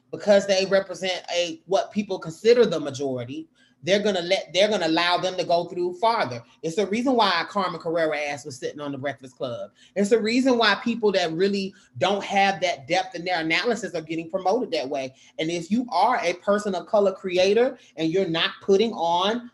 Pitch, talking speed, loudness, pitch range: 185 Hz, 205 wpm, -23 LUFS, 165-210 Hz